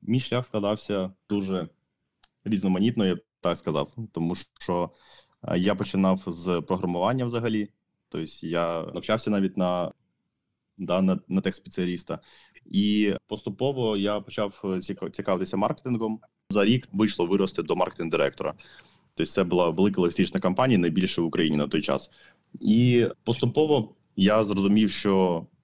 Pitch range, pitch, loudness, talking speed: 90-110 Hz, 100 Hz, -26 LUFS, 130 wpm